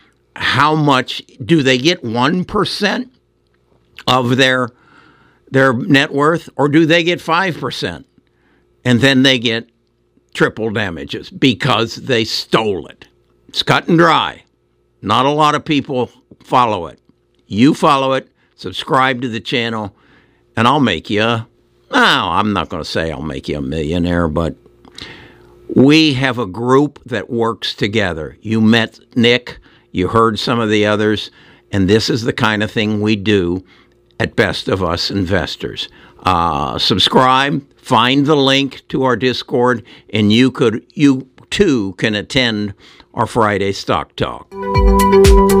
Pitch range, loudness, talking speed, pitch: 100-135 Hz, -15 LUFS, 145 wpm, 120 Hz